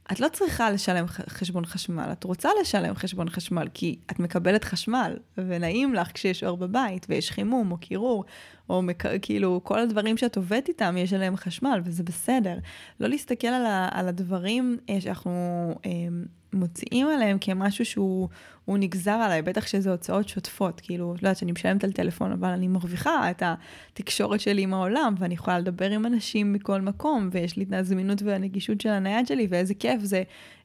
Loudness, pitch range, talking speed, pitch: -27 LUFS, 180-220 Hz, 170 wpm, 195 Hz